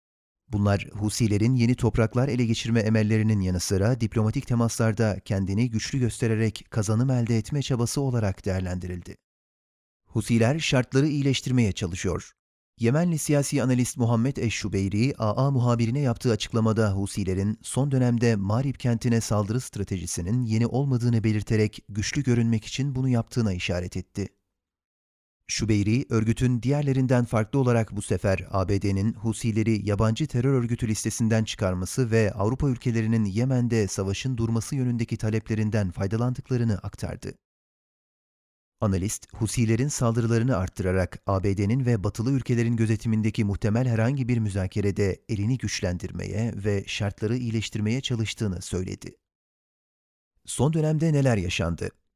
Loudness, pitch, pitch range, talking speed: -25 LUFS, 110 Hz, 100-125 Hz, 115 wpm